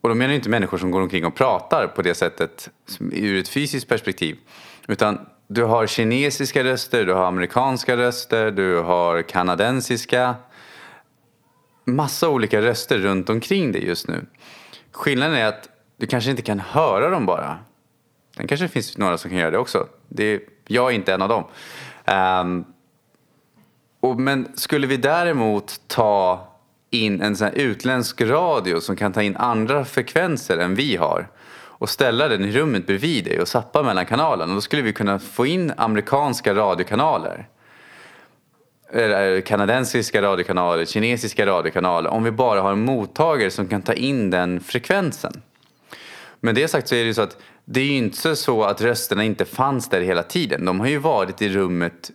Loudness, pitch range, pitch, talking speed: -20 LUFS, 95-125 Hz, 110 Hz, 165 wpm